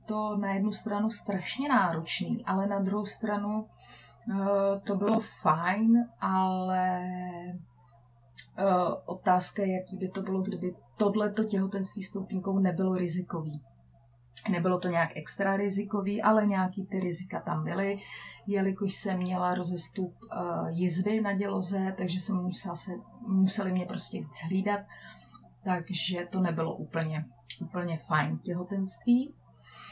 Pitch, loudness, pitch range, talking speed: 190 Hz, -30 LUFS, 175-200 Hz, 120 wpm